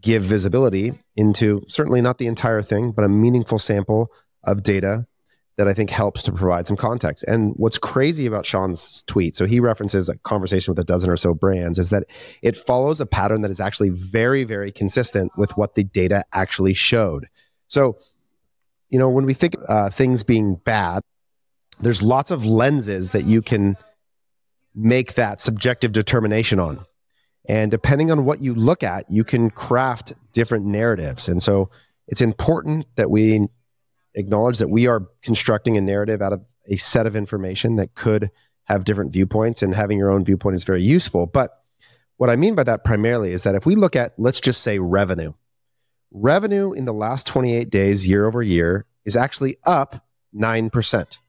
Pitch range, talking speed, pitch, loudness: 100-120 Hz, 180 wpm, 110 Hz, -19 LUFS